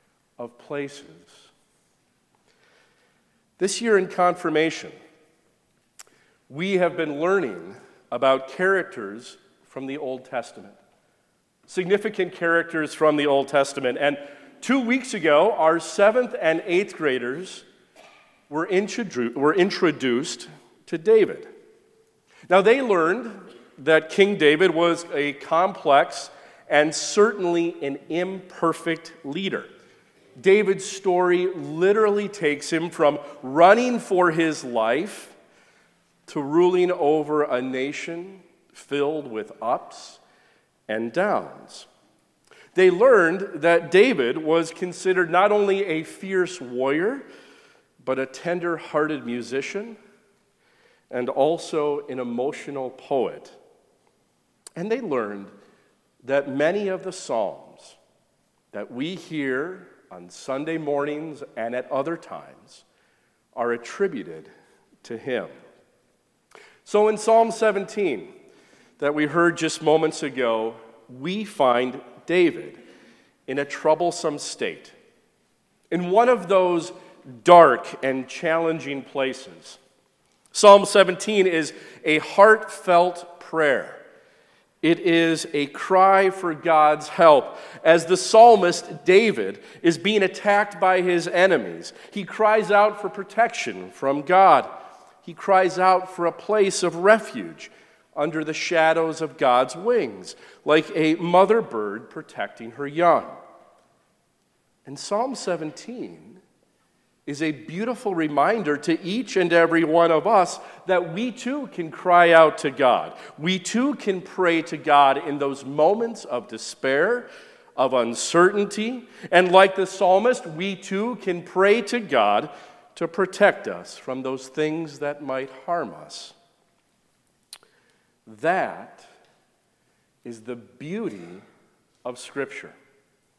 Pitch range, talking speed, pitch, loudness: 145-200 Hz, 110 wpm, 170 Hz, -21 LUFS